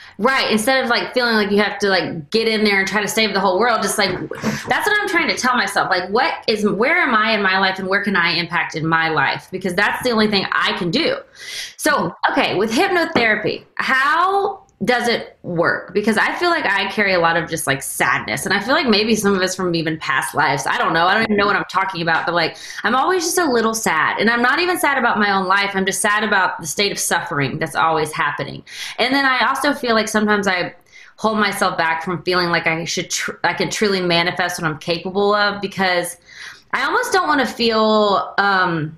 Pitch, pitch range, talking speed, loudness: 200 Hz, 175-225 Hz, 245 wpm, -17 LUFS